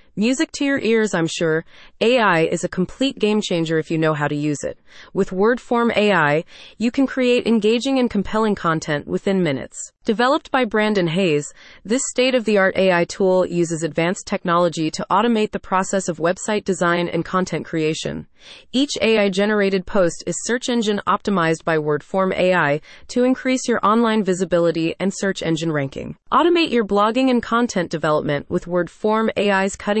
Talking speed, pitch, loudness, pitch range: 170 wpm, 195 Hz, -19 LUFS, 170-225 Hz